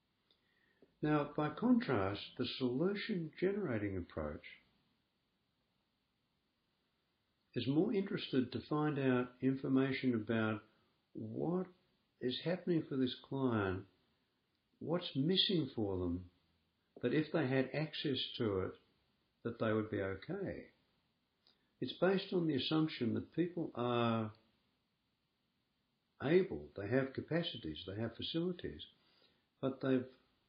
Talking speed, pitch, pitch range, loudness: 105 wpm, 130 Hz, 115-165 Hz, -38 LUFS